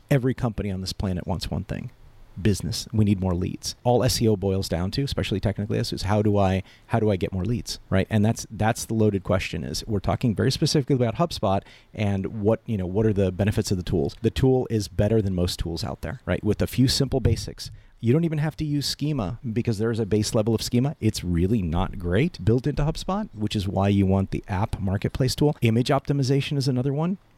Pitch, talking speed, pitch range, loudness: 110 Hz, 230 wpm, 95-125 Hz, -24 LUFS